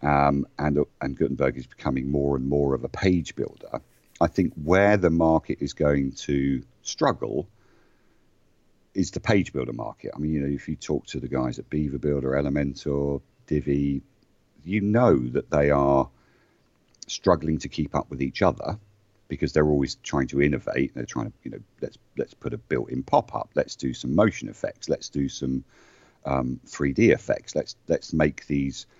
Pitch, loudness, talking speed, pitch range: 70 Hz, -25 LUFS, 180 wpm, 70-75 Hz